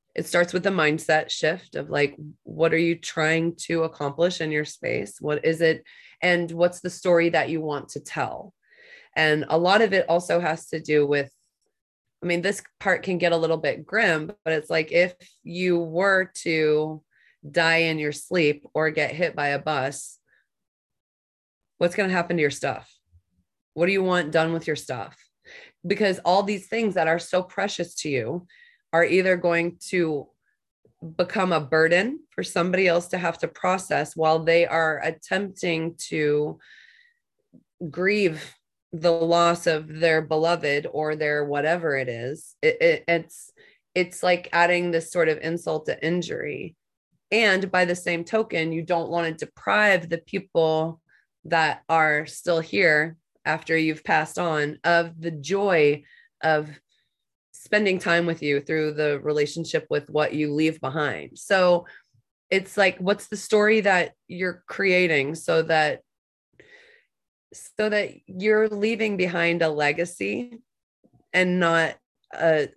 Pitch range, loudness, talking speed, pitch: 155-185 Hz, -23 LUFS, 155 wpm, 170 Hz